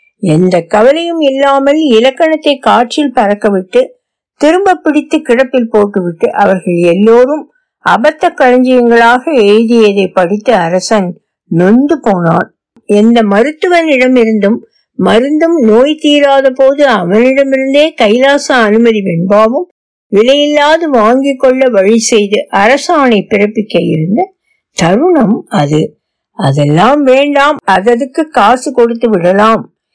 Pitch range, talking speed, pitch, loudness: 210-290 Hz, 90 wpm, 245 Hz, -8 LUFS